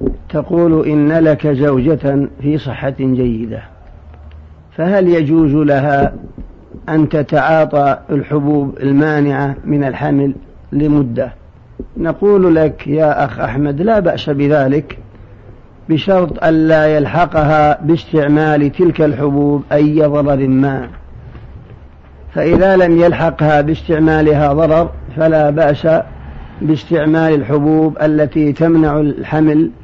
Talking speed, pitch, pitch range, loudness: 95 wpm, 150 Hz, 135-155 Hz, -13 LUFS